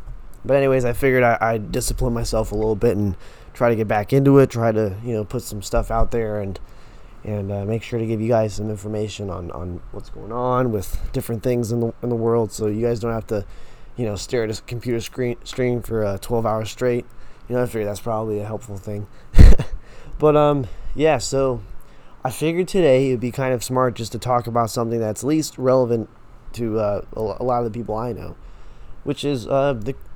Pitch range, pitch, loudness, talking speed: 105-125 Hz, 115 Hz, -21 LUFS, 220 wpm